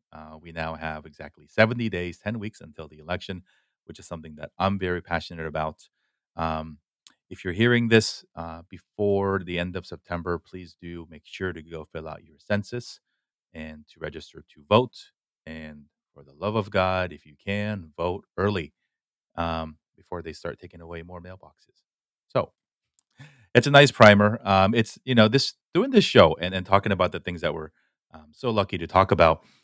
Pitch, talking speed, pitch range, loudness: 90 Hz, 185 wpm, 80-100 Hz, -23 LUFS